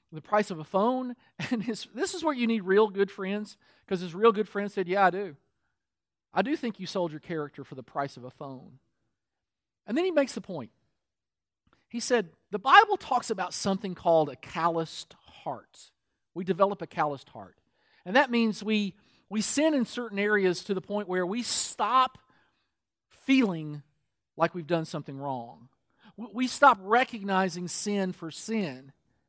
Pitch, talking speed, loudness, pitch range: 195 Hz, 175 wpm, -28 LUFS, 155-230 Hz